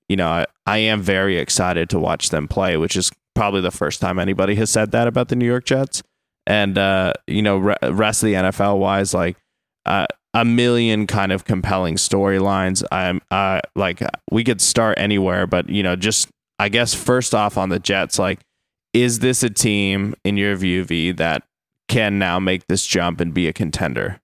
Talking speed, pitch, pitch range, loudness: 200 wpm, 100 Hz, 95-110 Hz, -18 LUFS